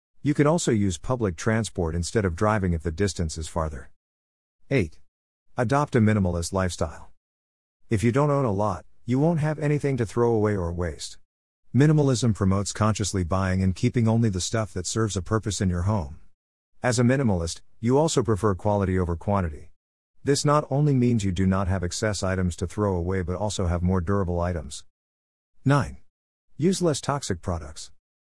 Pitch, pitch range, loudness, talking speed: 95 Hz, 85-115 Hz, -25 LUFS, 175 wpm